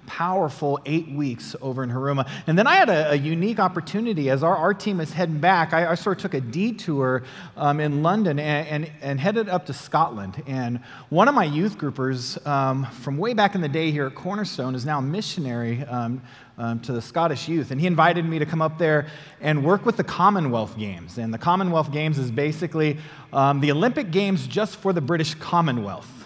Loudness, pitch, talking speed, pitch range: -23 LUFS, 150 Hz, 215 wpm, 135-175 Hz